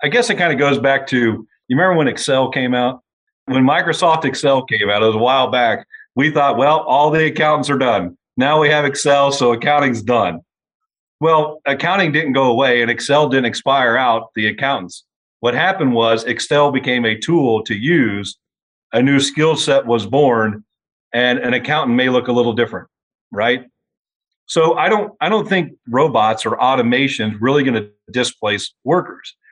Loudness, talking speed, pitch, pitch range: -15 LUFS, 185 wpm, 135 Hz, 120-150 Hz